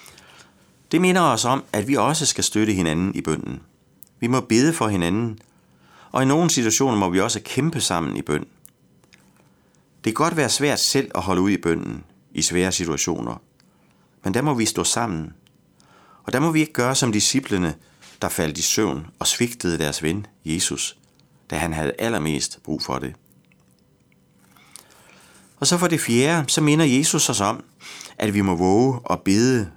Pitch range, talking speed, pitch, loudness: 90-135 Hz, 175 wpm, 110 Hz, -21 LUFS